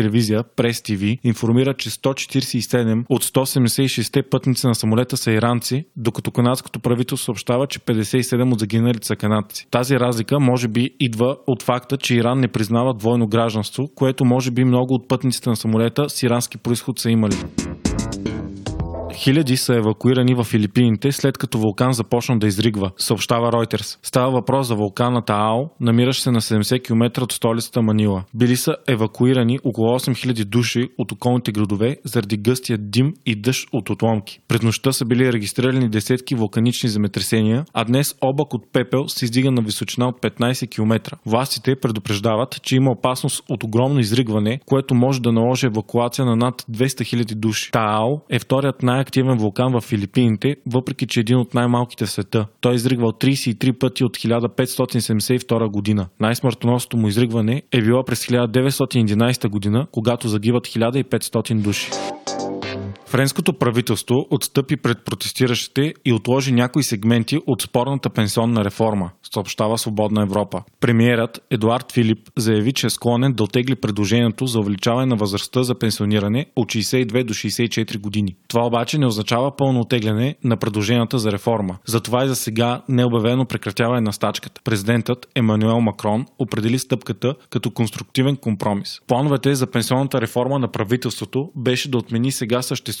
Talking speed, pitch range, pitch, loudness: 155 wpm, 110-130 Hz, 120 Hz, -19 LUFS